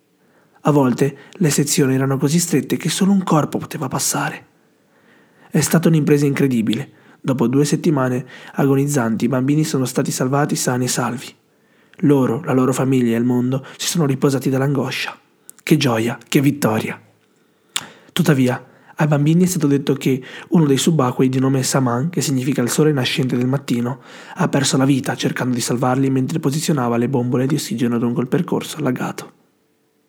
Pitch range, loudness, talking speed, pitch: 130-150 Hz, -18 LUFS, 160 wpm, 140 Hz